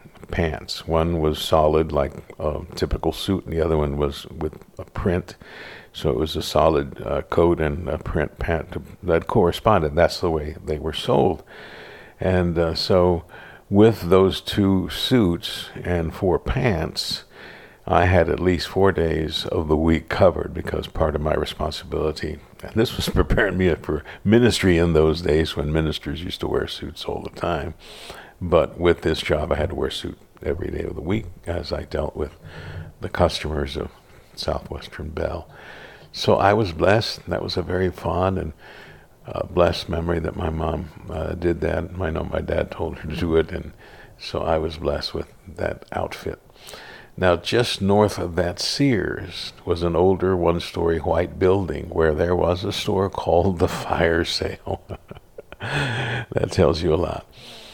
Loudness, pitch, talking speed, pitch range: -22 LUFS, 85 Hz, 170 wpm, 80-95 Hz